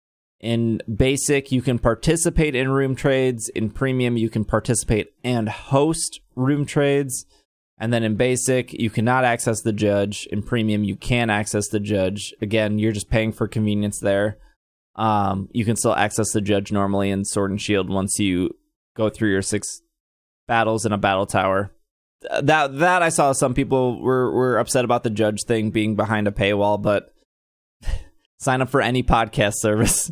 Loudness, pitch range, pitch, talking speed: -21 LUFS, 105-130 Hz, 110 Hz, 175 wpm